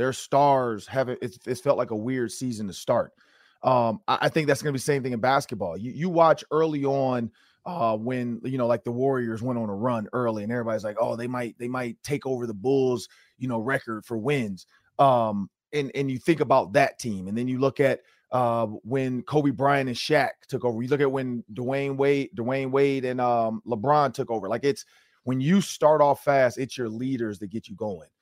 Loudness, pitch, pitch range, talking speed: -25 LUFS, 125 Hz, 115-140 Hz, 225 wpm